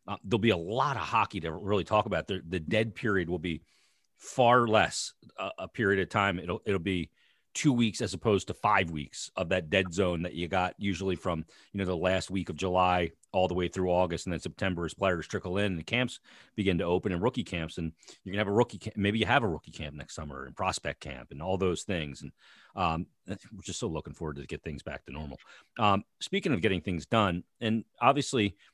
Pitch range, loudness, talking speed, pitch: 85-105 Hz, -30 LUFS, 235 wpm, 95 Hz